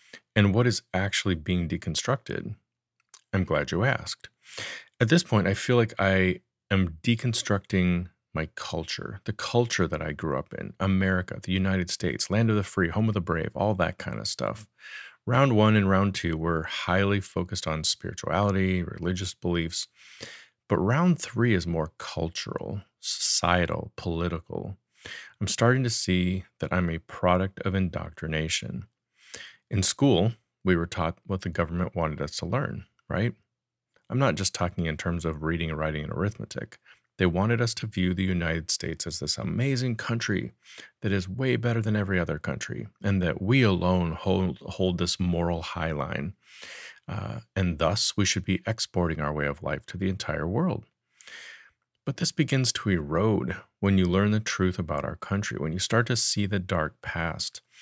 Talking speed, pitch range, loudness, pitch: 170 wpm, 85-110 Hz, -27 LUFS, 95 Hz